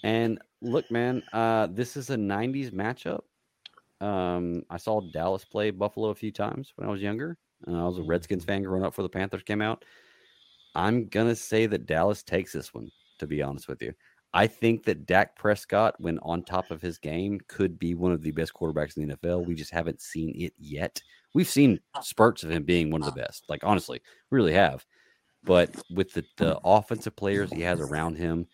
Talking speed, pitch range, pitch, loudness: 210 wpm, 85-110 Hz, 95 Hz, -28 LUFS